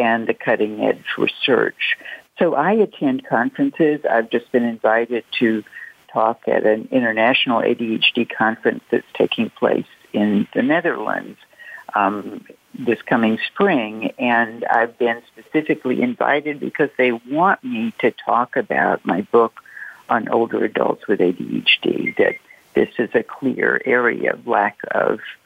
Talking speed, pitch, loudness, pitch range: 135 wpm, 120 Hz, -19 LUFS, 115-165 Hz